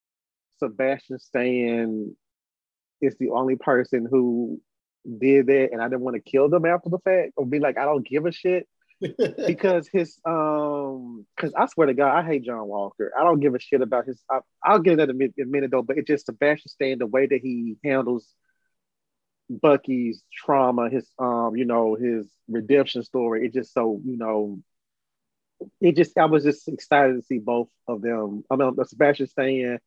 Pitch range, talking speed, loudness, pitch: 120-145 Hz, 190 wpm, -23 LUFS, 130 Hz